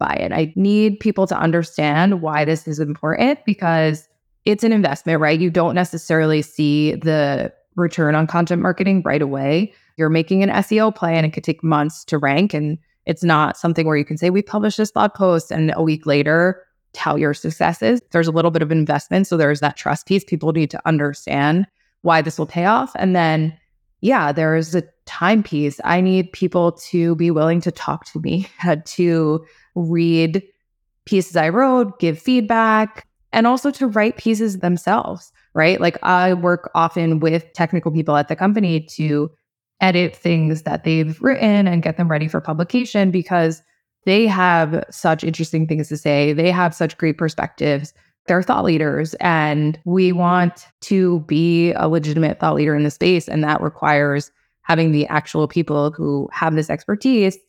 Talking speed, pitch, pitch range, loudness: 175 wpm, 165 Hz, 155-185 Hz, -18 LUFS